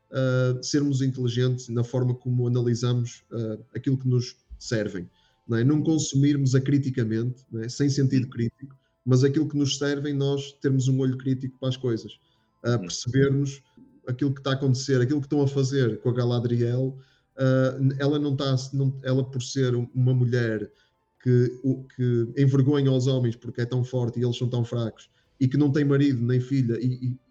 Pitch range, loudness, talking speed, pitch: 120-135 Hz, -25 LUFS, 180 wpm, 130 Hz